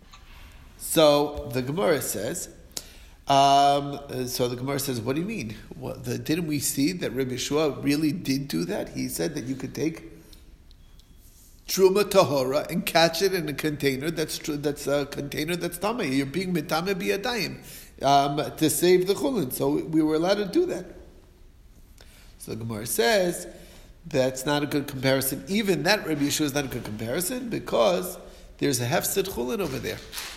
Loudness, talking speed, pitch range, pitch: -25 LUFS, 170 wpm, 135-170 Hz, 145 Hz